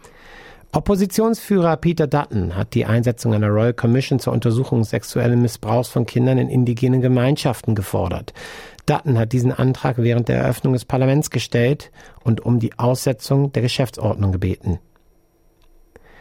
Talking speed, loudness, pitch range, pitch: 135 wpm, -19 LUFS, 115-135 Hz, 125 Hz